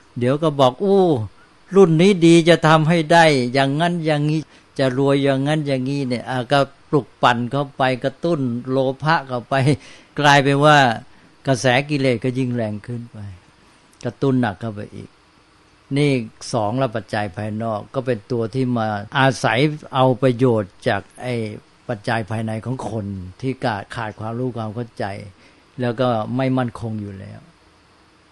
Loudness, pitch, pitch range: -19 LUFS, 130 Hz, 110-140 Hz